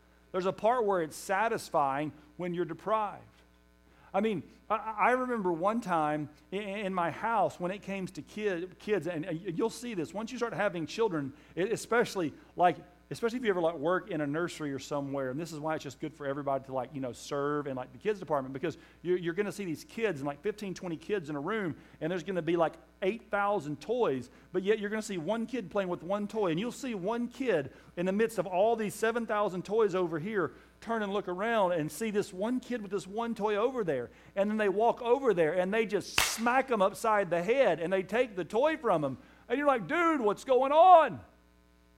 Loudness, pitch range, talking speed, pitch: -31 LUFS, 155-220 Hz, 225 wpm, 190 Hz